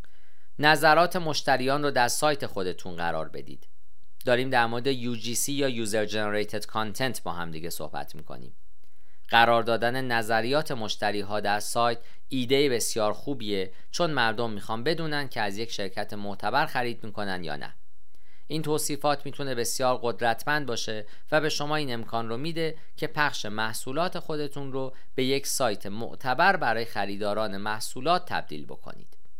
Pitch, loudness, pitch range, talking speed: 120 Hz, -27 LUFS, 105-140 Hz, 145 wpm